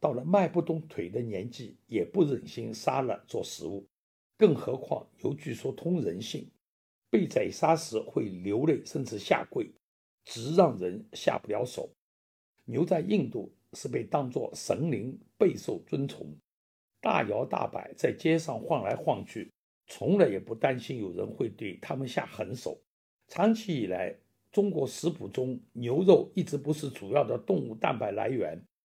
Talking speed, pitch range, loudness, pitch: 225 characters per minute, 115-170 Hz, -30 LUFS, 155 Hz